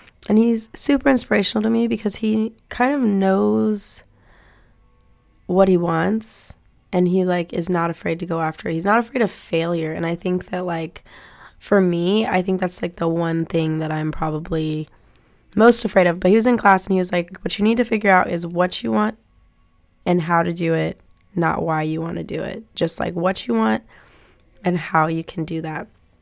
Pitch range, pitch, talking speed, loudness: 160-205 Hz, 175 Hz, 210 wpm, -20 LUFS